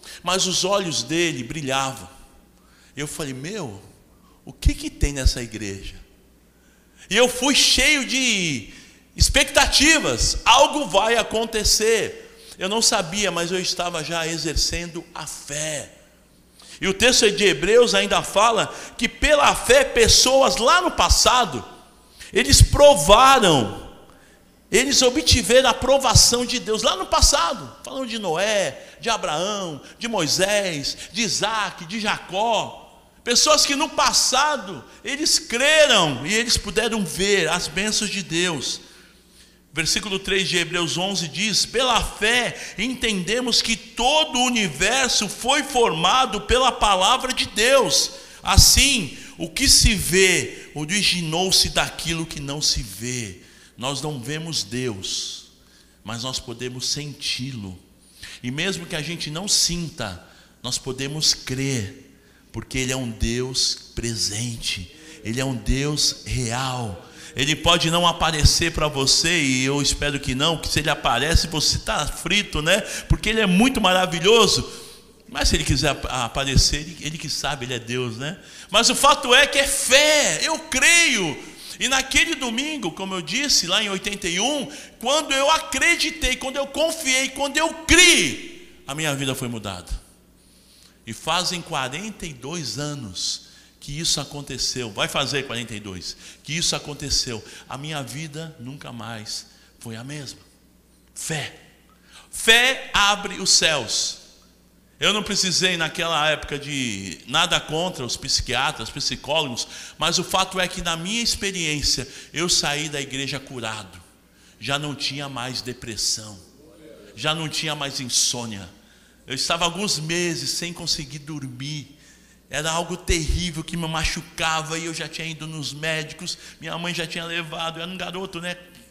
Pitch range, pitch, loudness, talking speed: 135-215 Hz, 165 Hz, -19 LUFS, 140 wpm